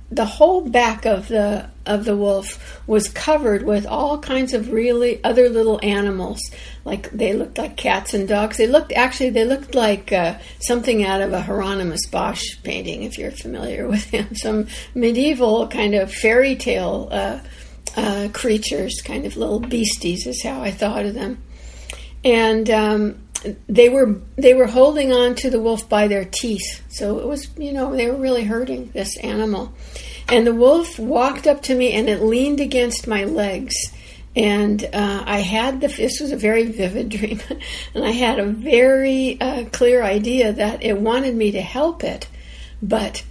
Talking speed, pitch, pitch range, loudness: 175 wpm, 225 Hz, 205-250 Hz, -19 LUFS